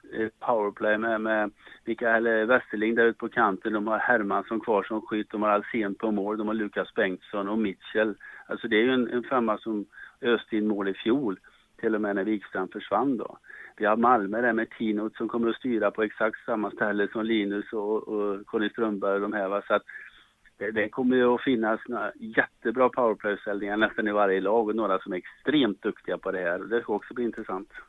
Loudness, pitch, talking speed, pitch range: -27 LUFS, 110 Hz, 205 wpm, 105-115 Hz